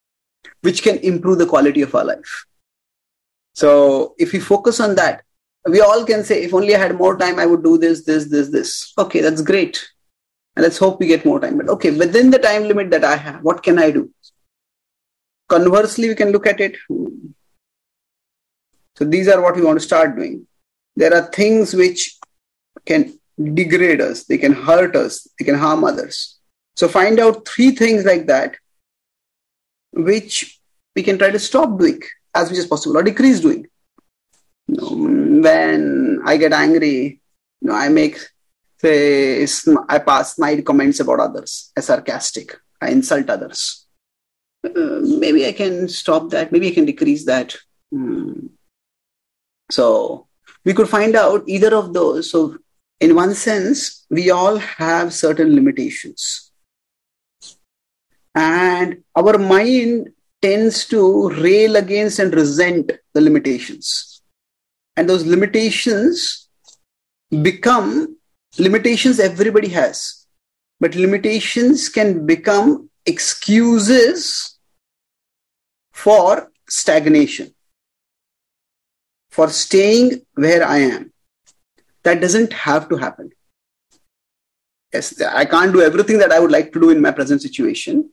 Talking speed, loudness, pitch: 140 wpm, -15 LUFS, 210 Hz